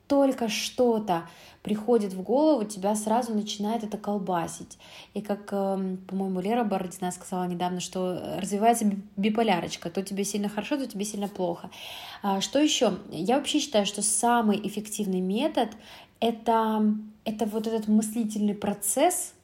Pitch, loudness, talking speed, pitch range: 210 Hz, -27 LUFS, 135 wpm, 195-230 Hz